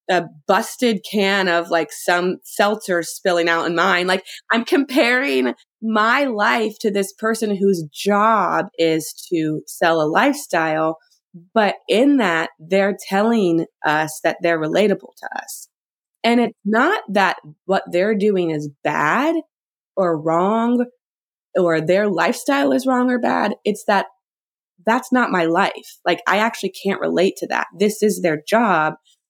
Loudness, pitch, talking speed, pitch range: -19 LUFS, 195 Hz, 145 wpm, 170-225 Hz